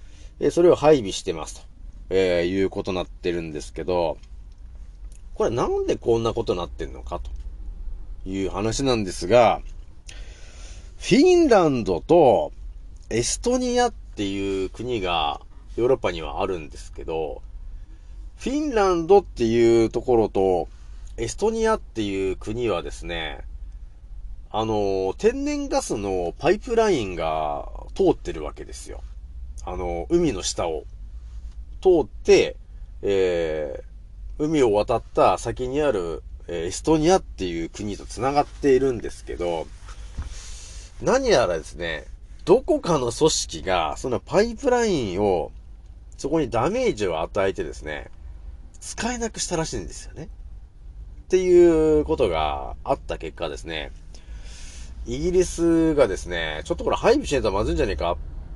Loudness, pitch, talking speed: -23 LUFS, 95 Hz, 280 characters per minute